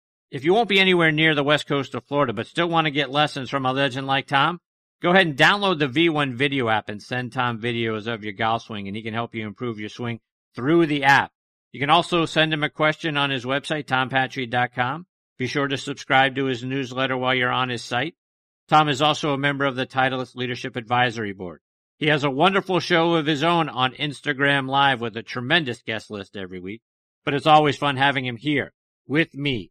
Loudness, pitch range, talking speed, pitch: -21 LUFS, 125-150 Hz, 220 wpm, 135 Hz